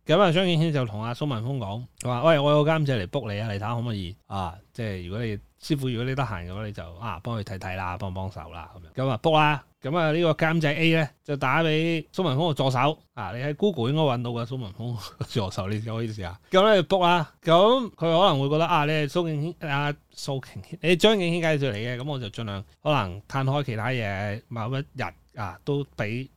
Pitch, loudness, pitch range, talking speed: 130 Hz, -25 LUFS, 110-155 Hz, 360 characters per minute